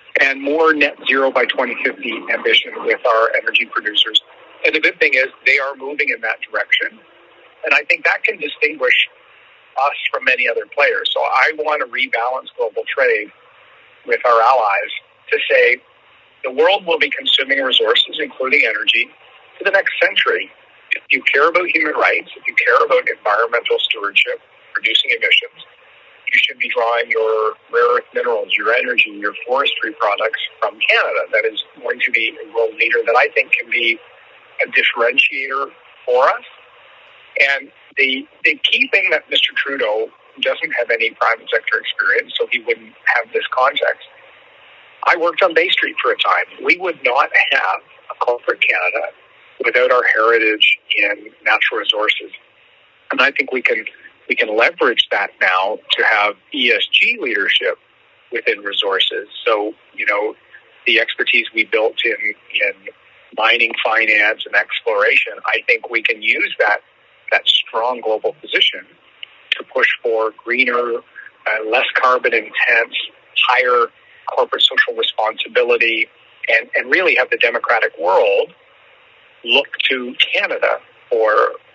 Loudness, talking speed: -15 LUFS, 150 wpm